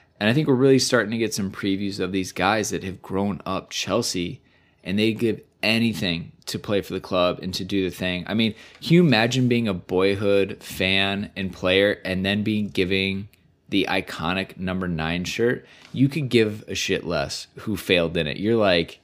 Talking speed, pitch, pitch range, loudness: 200 wpm, 100 Hz, 95-110 Hz, -23 LUFS